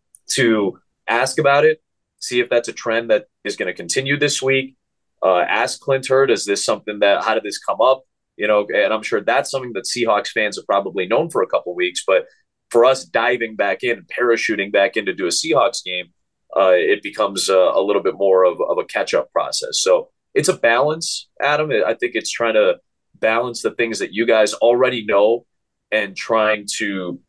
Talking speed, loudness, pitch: 210 wpm, -18 LUFS, 145 Hz